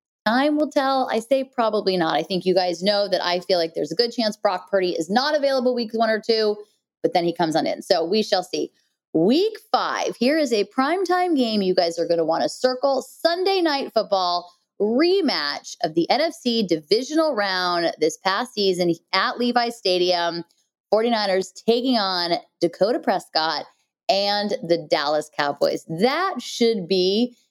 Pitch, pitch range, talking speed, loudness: 210 Hz, 180-250 Hz, 175 wpm, -21 LUFS